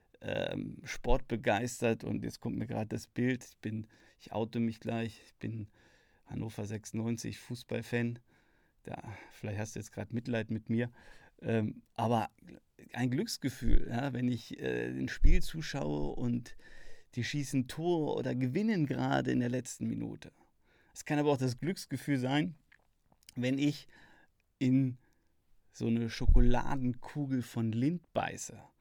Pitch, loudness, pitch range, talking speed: 120 Hz, -35 LUFS, 110-130 Hz, 135 wpm